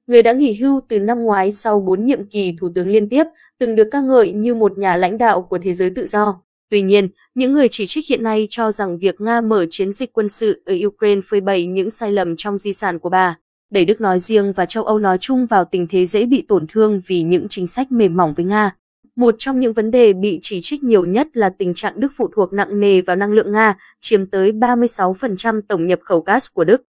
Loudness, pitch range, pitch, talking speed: -16 LUFS, 190-235 Hz, 205 Hz, 250 wpm